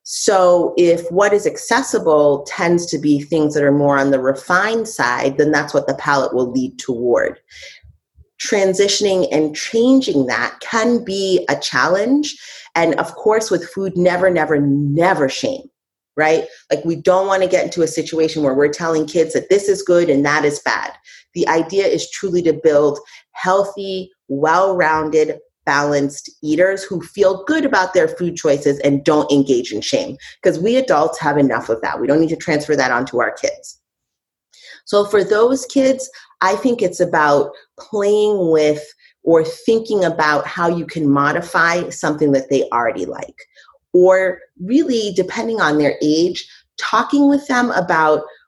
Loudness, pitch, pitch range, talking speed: -16 LUFS, 170 Hz, 150-200 Hz, 165 wpm